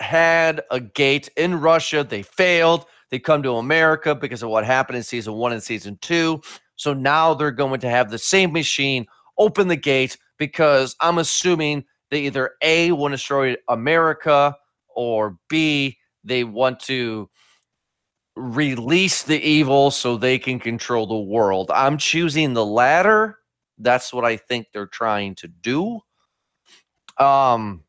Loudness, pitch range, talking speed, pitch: -19 LUFS, 120-160 Hz, 150 wpm, 140 Hz